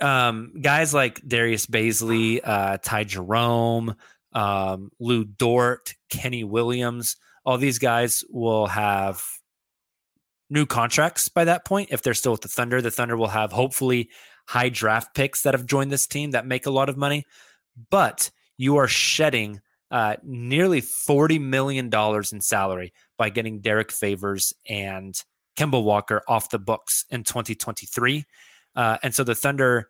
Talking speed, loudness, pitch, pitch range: 150 wpm, -23 LUFS, 120 Hz, 110-135 Hz